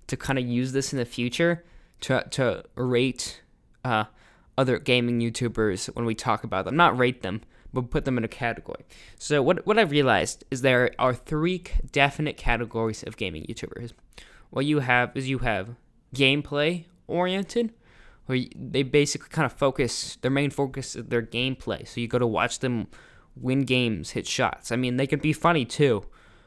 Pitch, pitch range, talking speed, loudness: 125 Hz, 115-140 Hz, 180 wpm, -25 LUFS